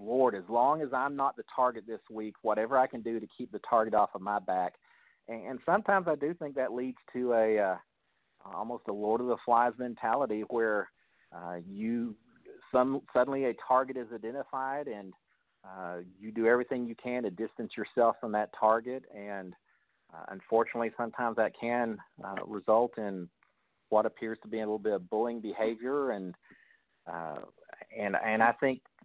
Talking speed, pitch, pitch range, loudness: 180 wpm, 115 Hz, 110-130 Hz, -32 LUFS